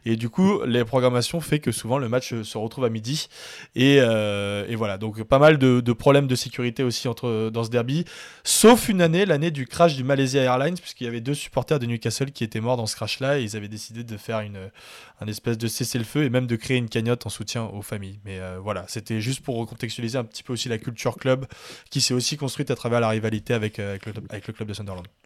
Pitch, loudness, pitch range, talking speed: 120 Hz, -23 LUFS, 110-135 Hz, 250 wpm